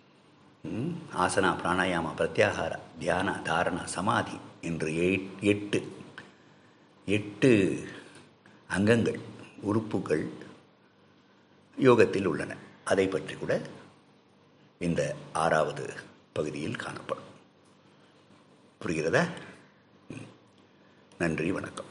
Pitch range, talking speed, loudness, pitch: 85-100 Hz, 65 wpm, -29 LUFS, 95 Hz